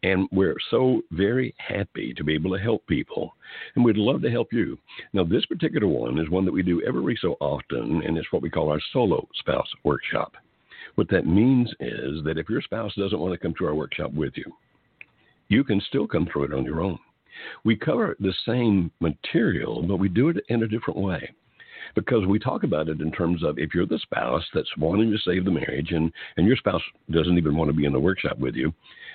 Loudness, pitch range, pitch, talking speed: -25 LUFS, 80-105 Hz, 90 Hz, 225 wpm